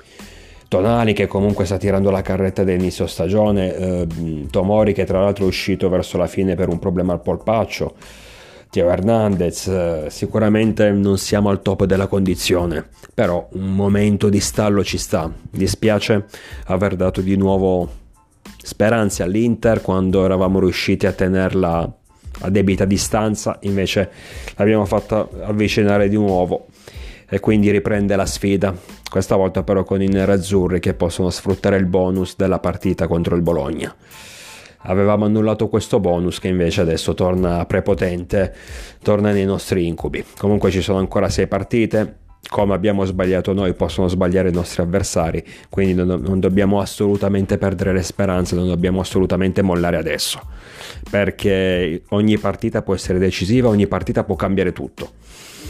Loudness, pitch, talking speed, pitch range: -18 LUFS, 95 Hz, 145 wpm, 90-100 Hz